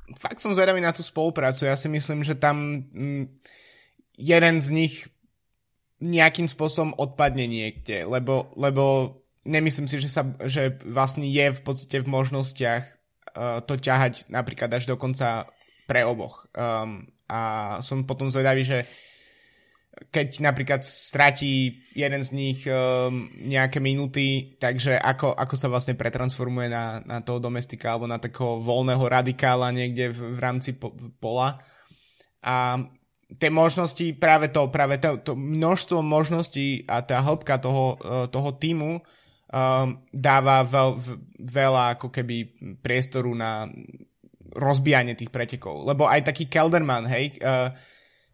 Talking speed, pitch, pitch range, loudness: 140 wpm, 135 Hz, 125-145 Hz, -24 LUFS